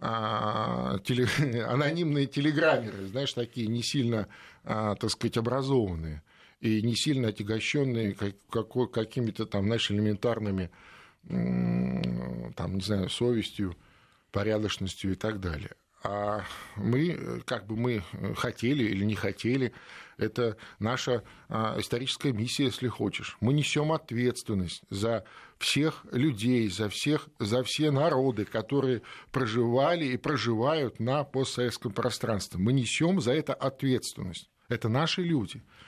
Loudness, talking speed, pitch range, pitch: -30 LUFS, 115 wpm, 105-130 Hz, 115 Hz